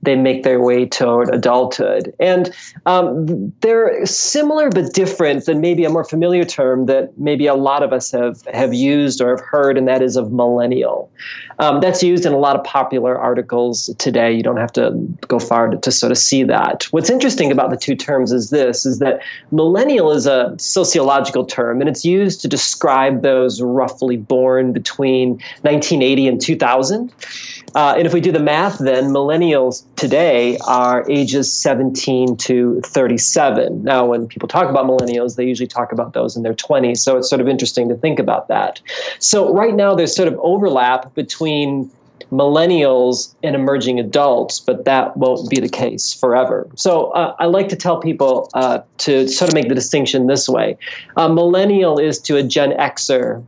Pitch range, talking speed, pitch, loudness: 125-160 Hz, 185 wpm, 135 Hz, -15 LUFS